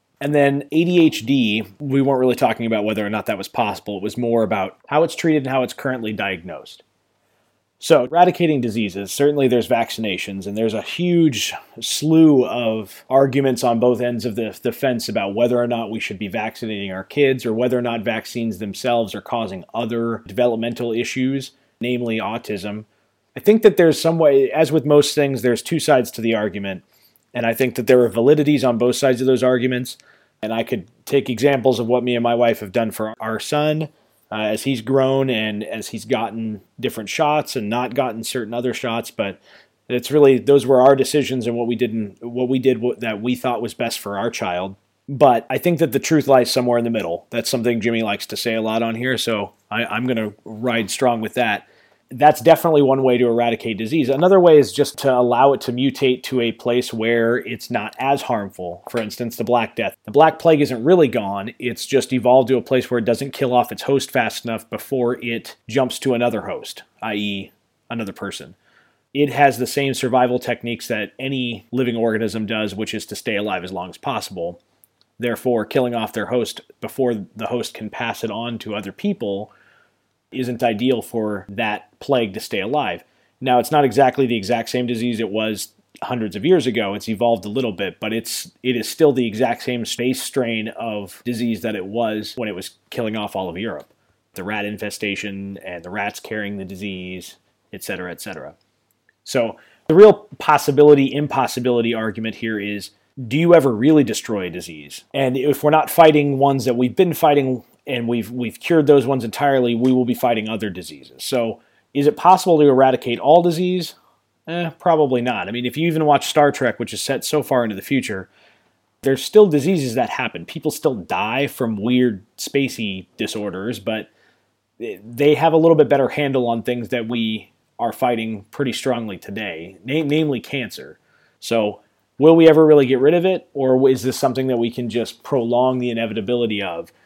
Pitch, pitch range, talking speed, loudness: 120 Hz, 110-135 Hz, 200 wpm, -19 LUFS